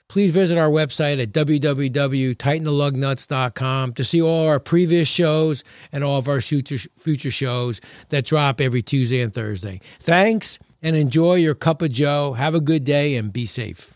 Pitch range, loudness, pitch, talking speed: 130-155 Hz, -20 LUFS, 145 Hz, 170 wpm